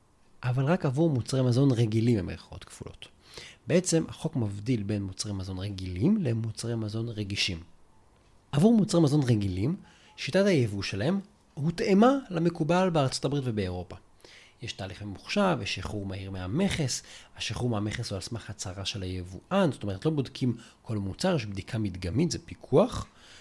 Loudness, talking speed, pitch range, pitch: -28 LUFS, 145 wpm, 100-155 Hz, 115 Hz